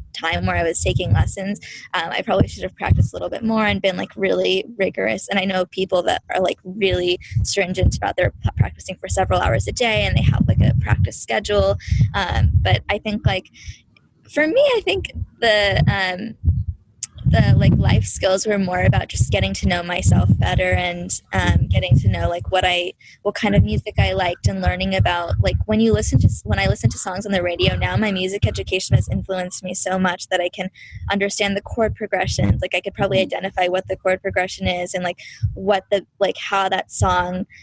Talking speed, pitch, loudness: 210 wpm, 185 Hz, -19 LUFS